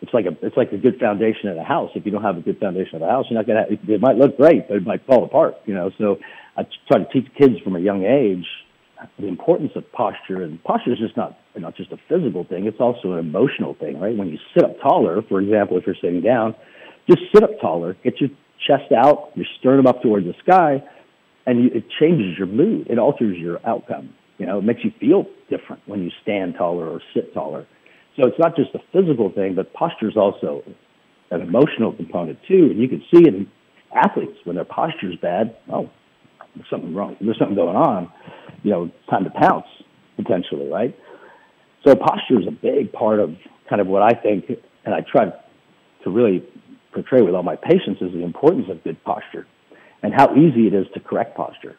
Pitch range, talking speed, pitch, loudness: 95-145 Hz, 225 wpm, 115 Hz, -19 LUFS